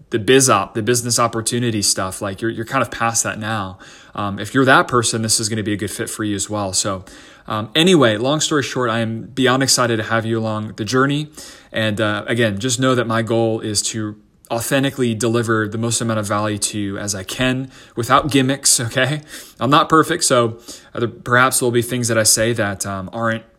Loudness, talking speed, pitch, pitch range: -17 LUFS, 220 wpm, 115 Hz, 110-130 Hz